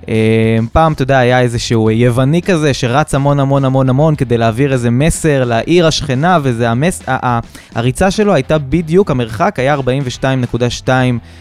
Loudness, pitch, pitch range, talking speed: -12 LUFS, 130 Hz, 120-150 Hz, 145 wpm